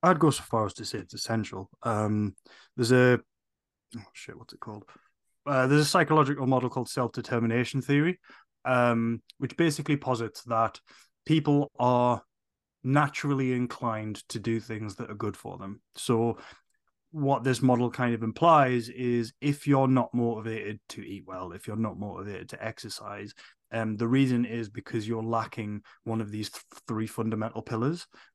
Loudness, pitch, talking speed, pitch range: -28 LUFS, 120 Hz, 165 wpm, 110-130 Hz